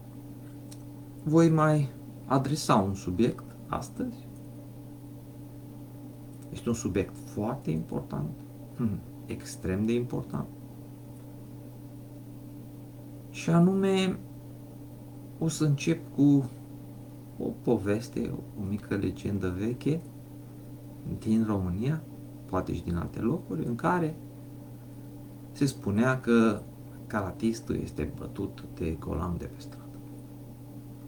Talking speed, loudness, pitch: 85 wpm, -30 LUFS, 90 Hz